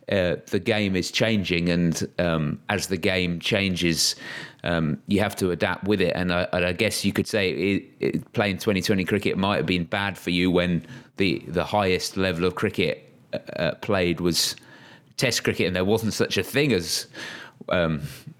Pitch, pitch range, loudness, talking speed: 90 Hz, 90-105 Hz, -24 LUFS, 185 wpm